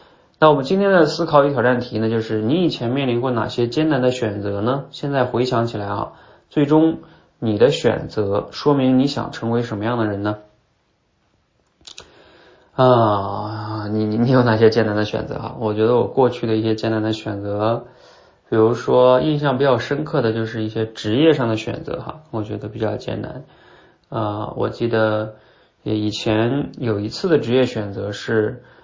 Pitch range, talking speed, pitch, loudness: 110-130 Hz, 260 characters per minute, 115 Hz, -19 LUFS